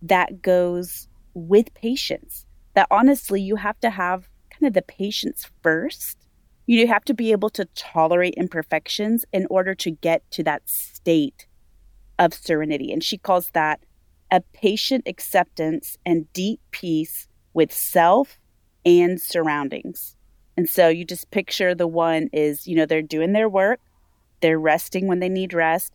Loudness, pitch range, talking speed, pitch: -21 LUFS, 160-195 Hz, 155 wpm, 175 Hz